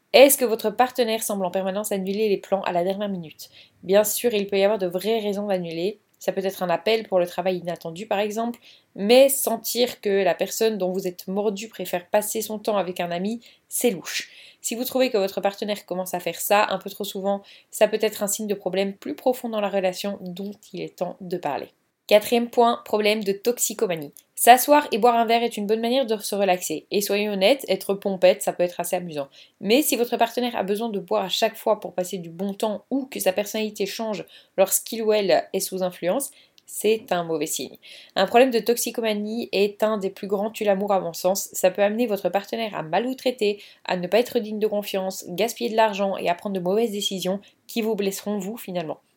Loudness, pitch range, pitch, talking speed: -23 LUFS, 190-225 Hz, 205 Hz, 225 wpm